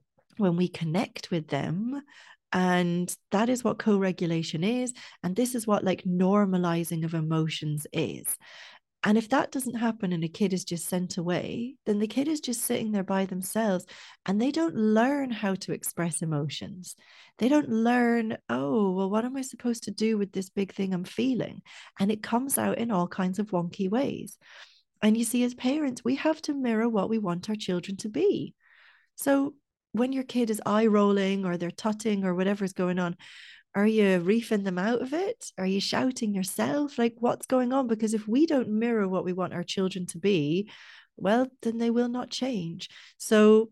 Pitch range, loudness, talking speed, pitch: 185-240 Hz, -28 LUFS, 195 wpm, 210 Hz